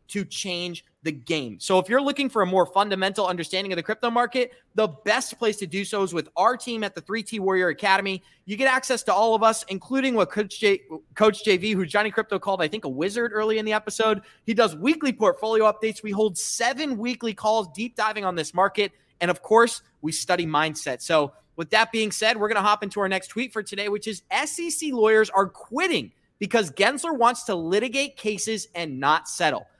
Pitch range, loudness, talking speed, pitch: 190-225 Hz, -24 LUFS, 220 wpm, 210 Hz